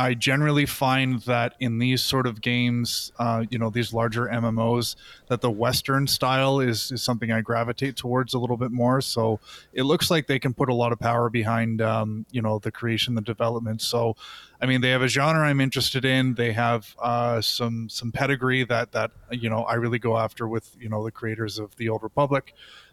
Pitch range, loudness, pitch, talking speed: 115-130 Hz, -24 LUFS, 120 Hz, 210 wpm